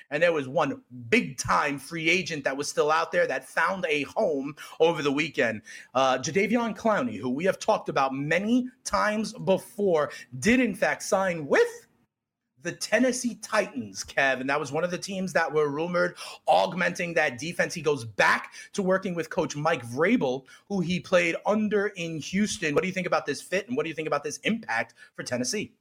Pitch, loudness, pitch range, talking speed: 175 Hz, -26 LUFS, 145-210 Hz, 200 wpm